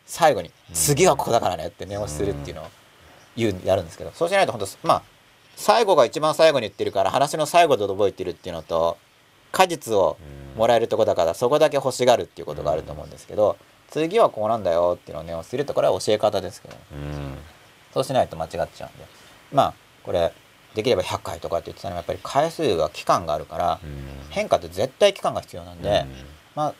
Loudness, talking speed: -22 LUFS, 460 characters per minute